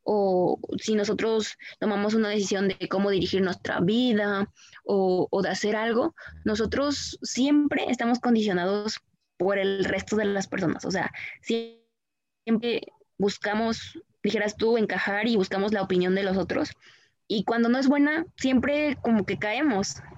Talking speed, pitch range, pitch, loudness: 145 wpm, 195-235 Hz, 210 Hz, -26 LUFS